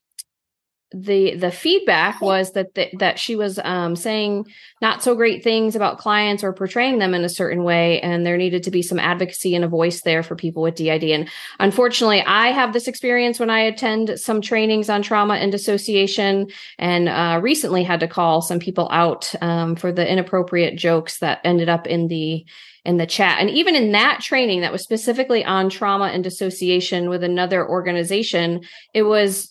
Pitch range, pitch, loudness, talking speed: 175-215 Hz, 190 Hz, -19 LUFS, 190 wpm